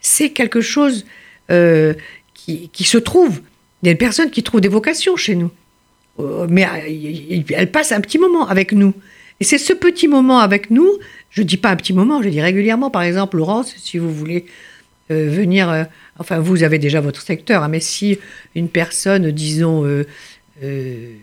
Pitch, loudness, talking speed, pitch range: 190 Hz, -15 LUFS, 190 wpm, 160-230 Hz